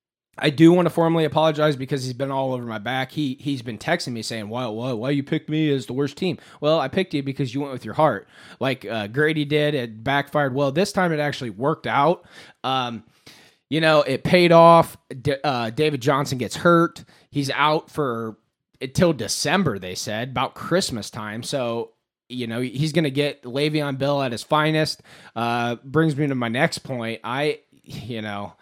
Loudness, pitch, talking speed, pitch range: -22 LUFS, 140 Hz, 205 wpm, 120-155 Hz